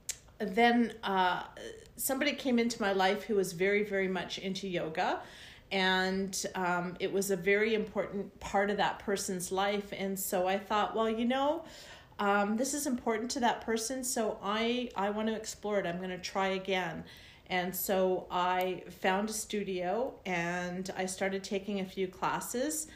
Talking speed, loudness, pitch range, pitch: 175 wpm, -32 LUFS, 185-225 Hz, 195 Hz